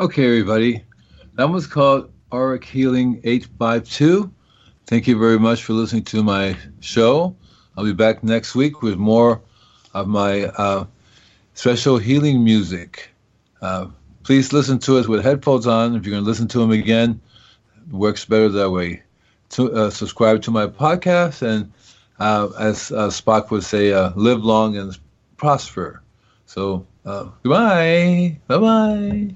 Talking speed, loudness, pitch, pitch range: 150 wpm, -18 LUFS, 115 Hz, 105-130 Hz